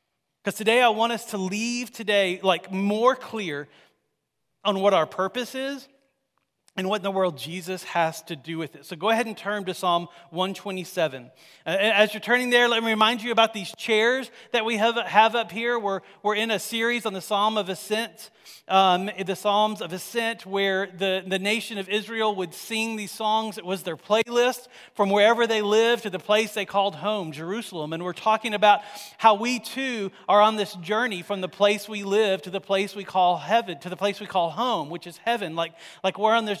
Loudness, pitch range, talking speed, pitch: -24 LUFS, 190-225 Hz, 210 wpm, 205 Hz